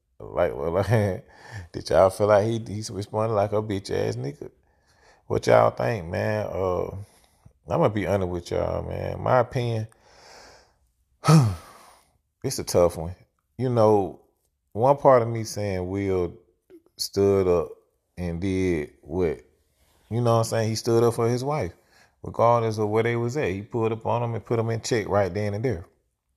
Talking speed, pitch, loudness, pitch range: 180 wpm, 105 Hz, -24 LUFS, 90-115 Hz